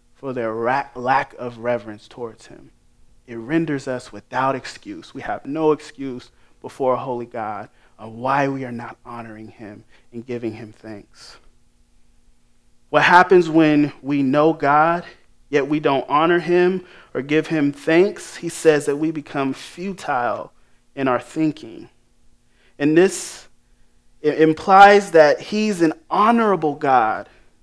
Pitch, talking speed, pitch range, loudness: 135 Hz, 135 wpm, 115-160 Hz, -18 LUFS